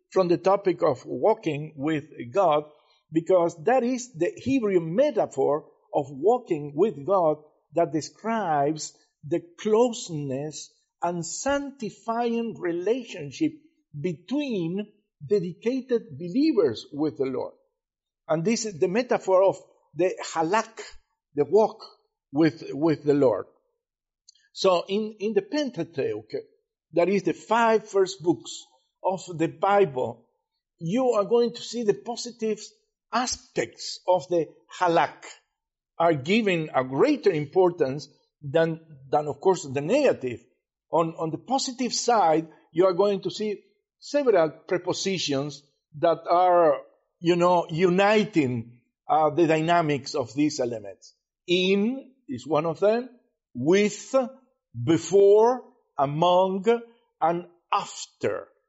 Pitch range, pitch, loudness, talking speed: 165-235 Hz, 190 Hz, -25 LUFS, 115 wpm